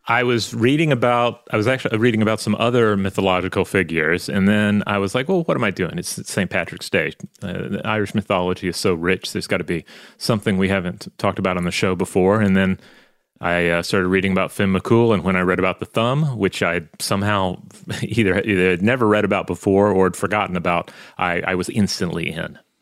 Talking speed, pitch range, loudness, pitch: 215 wpm, 95-110 Hz, -19 LUFS, 100 Hz